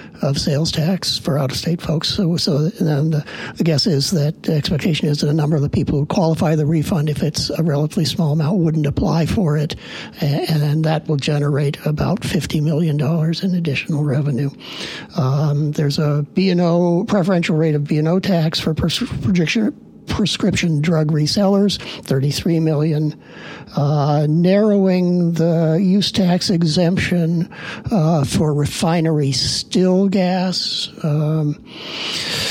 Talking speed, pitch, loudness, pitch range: 150 wpm, 160 Hz, -18 LUFS, 150-175 Hz